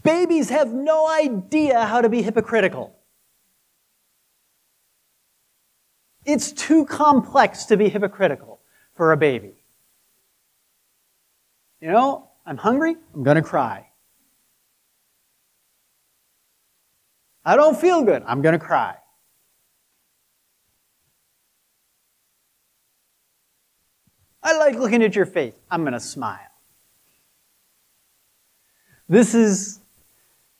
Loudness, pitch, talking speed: -19 LUFS, 225 Hz, 80 wpm